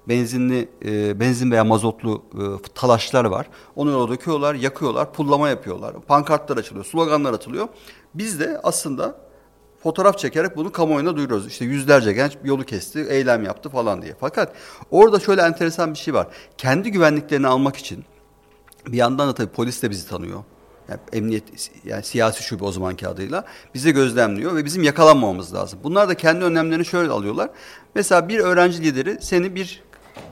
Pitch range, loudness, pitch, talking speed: 120-165 Hz, -20 LUFS, 140 Hz, 160 wpm